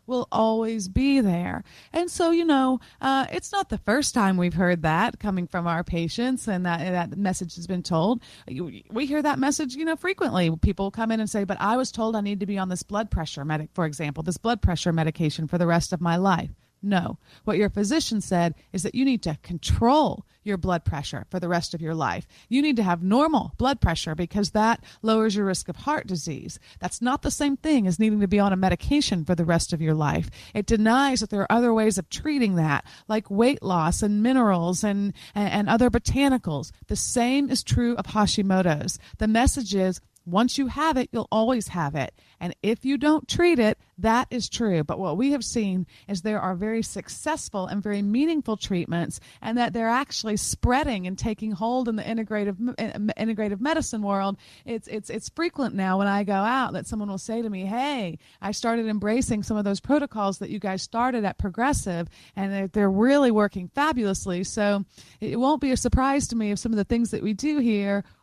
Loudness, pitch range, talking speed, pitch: -25 LUFS, 185-245 Hz, 215 wpm, 210 Hz